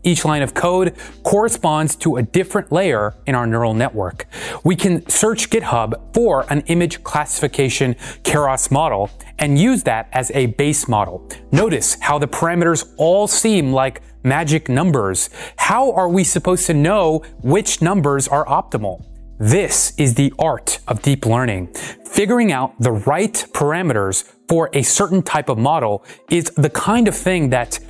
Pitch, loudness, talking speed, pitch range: 155 Hz, -17 LUFS, 155 wpm, 130-185 Hz